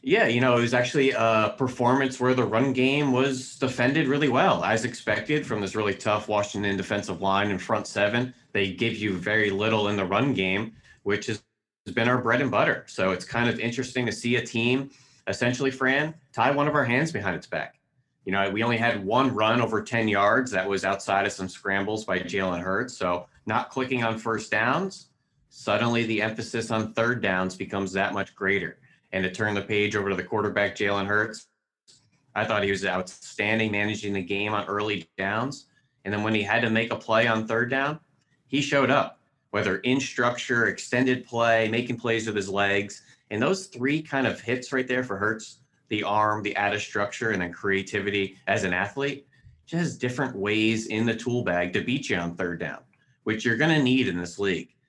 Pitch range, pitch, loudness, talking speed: 100-125 Hz, 110 Hz, -25 LUFS, 200 wpm